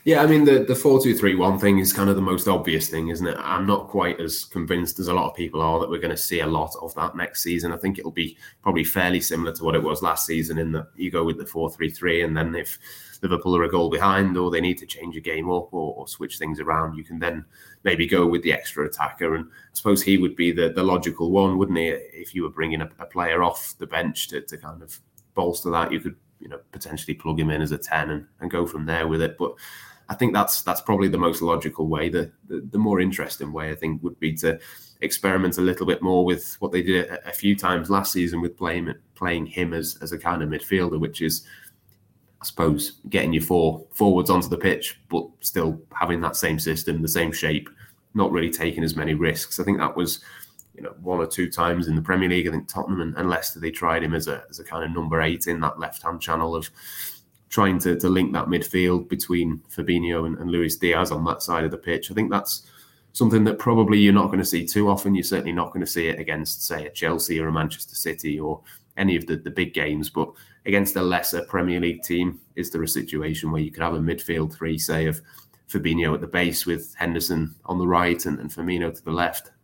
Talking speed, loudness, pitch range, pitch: 250 wpm, -23 LUFS, 80-90 Hz, 85 Hz